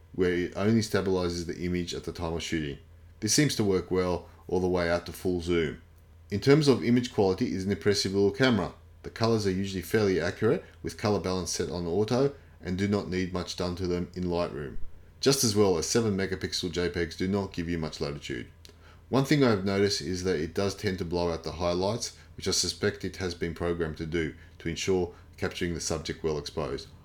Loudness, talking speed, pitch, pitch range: -29 LUFS, 220 wpm, 90 Hz, 85-100 Hz